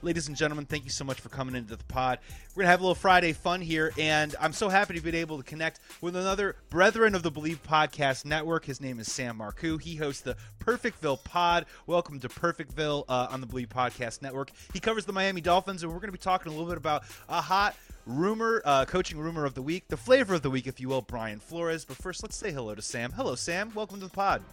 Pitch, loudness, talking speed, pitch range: 160 Hz, -29 LUFS, 255 wpm, 135-180 Hz